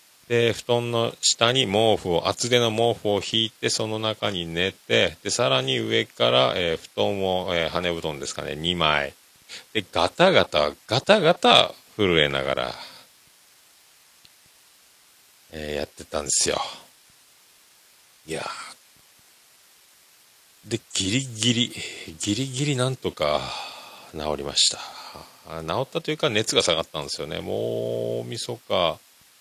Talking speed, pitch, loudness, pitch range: 235 characters per minute, 100 Hz, -23 LUFS, 80-120 Hz